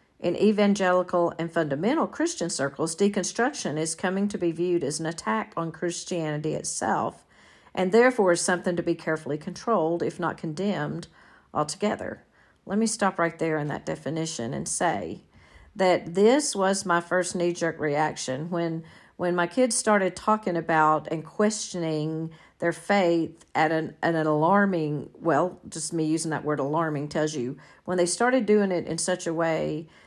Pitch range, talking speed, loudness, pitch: 160-190 Hz, 165 wpm, -26 LUFS, 170 Hz